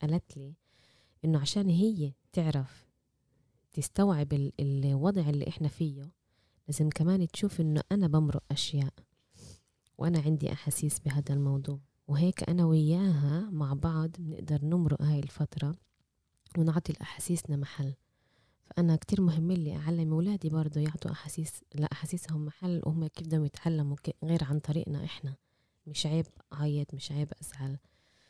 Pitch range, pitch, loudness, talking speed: 140-165 Hz, 150 Hz, -31 LUFS, 125 wpm